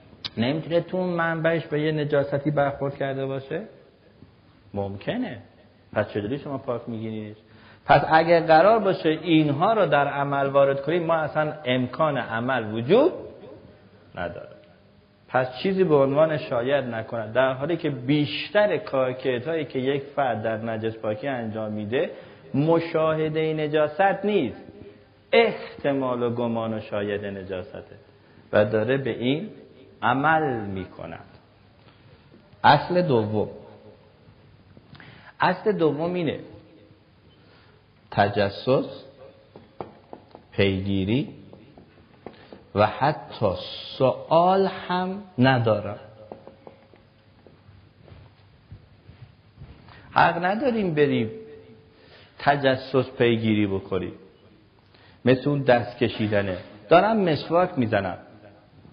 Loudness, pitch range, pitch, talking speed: -23 LUFS, 105-150 Hz, 125 Hz, 95 wpm